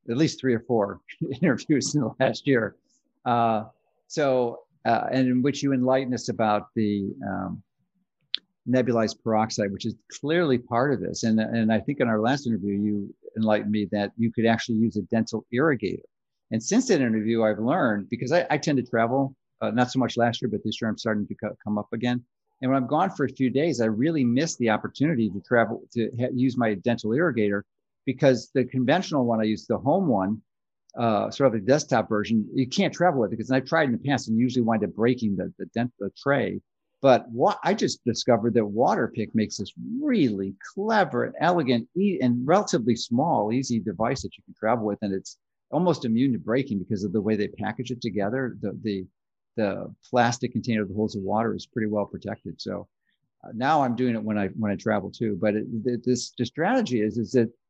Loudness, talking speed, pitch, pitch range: -25 LUFS, 215 wpm, 115 Hz, 110-130 Hz